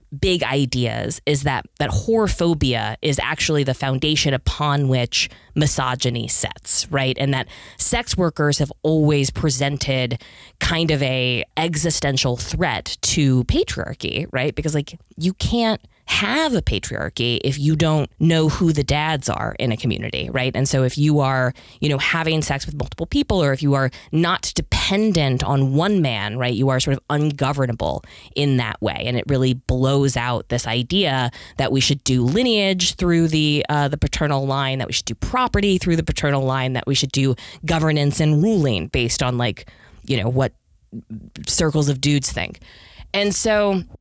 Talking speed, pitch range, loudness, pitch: 170 wpm, 125-155 Hz, -19 LUFS, 140 Hz